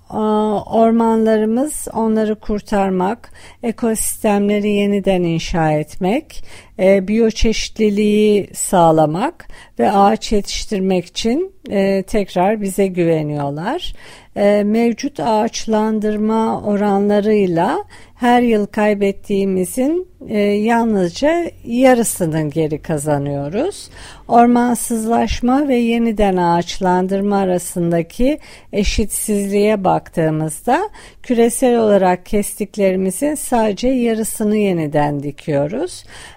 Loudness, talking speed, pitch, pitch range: -16 LUFS, 75 wpm, 210 Hz, 185-230 Hz